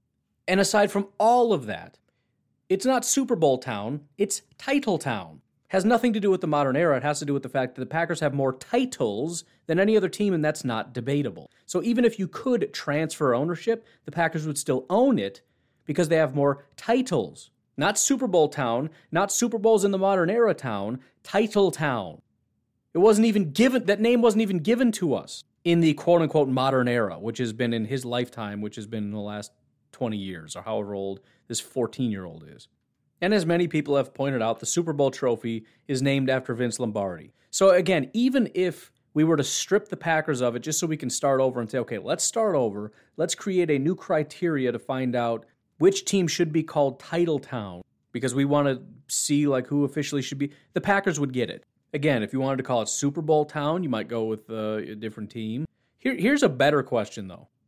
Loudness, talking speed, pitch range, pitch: -25 LUFS, 215 wpm, 125-190 Hz, 145 Hz